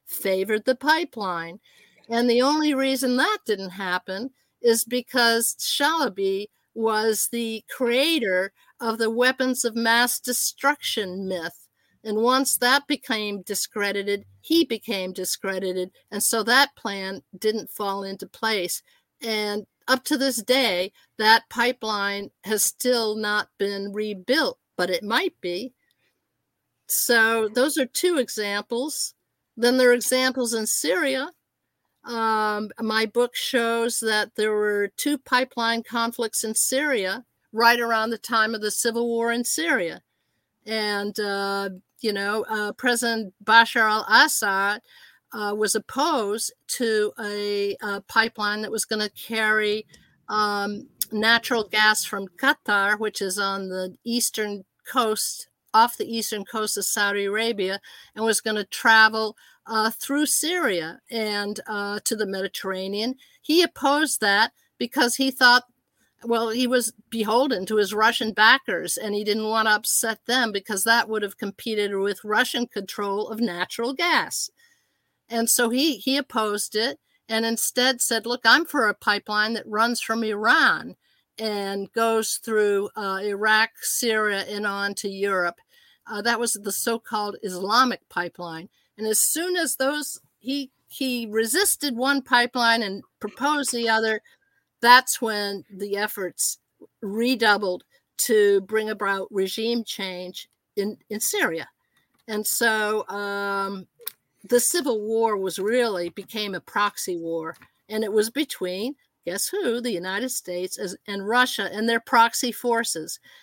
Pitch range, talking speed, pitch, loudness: 205-245 Hz, 140 wpm, 220 Hz, -23 LUFS